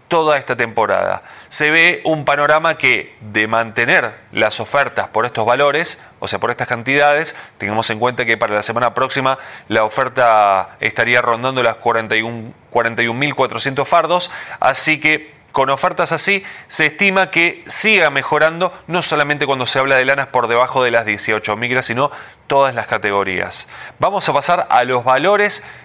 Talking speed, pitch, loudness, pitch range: 160 wpm, 130 Hz, -15 LUFS, 115-155 Hz